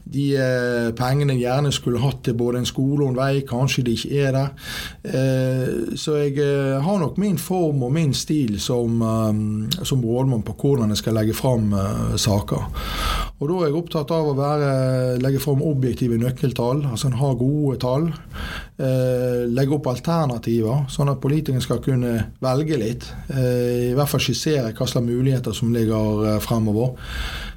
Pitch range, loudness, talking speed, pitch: 120-140 Hz, -21 LUFS, 160 wpm, 130 Hz